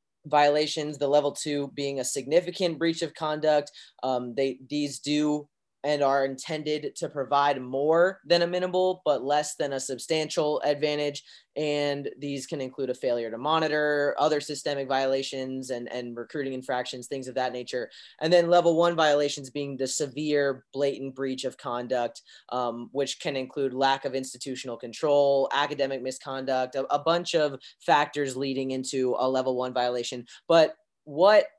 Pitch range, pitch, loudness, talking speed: 130-150 Hz, 140 Hz, -27 LUFS, 160 wpm